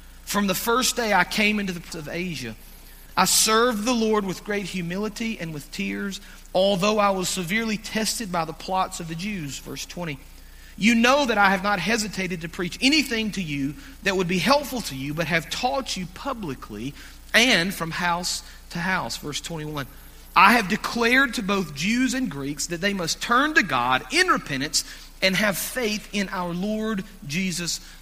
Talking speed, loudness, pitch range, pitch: 185 wpm, -23 LUFS, 170-220 Hz, 190 Hz